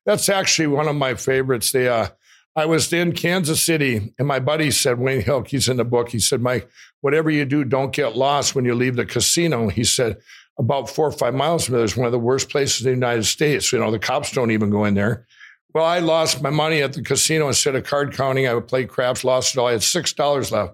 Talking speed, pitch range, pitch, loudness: 260 wpm, 120-150 Hz, 135 Hz, -19 LUFS